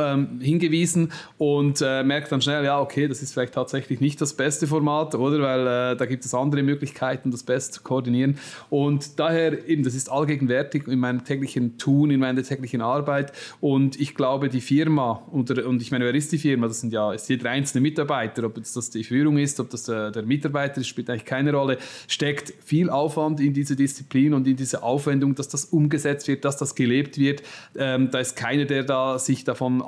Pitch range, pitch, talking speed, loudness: 130-145 Hz, 140 Hz, 205 wpm, -23 LUFS